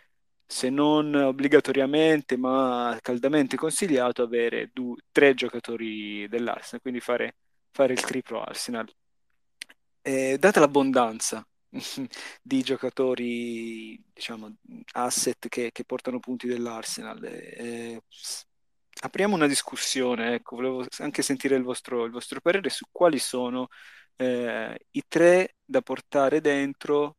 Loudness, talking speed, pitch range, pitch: -26 LUFS, 110 wpm, 120-140 Hz, 130 Hz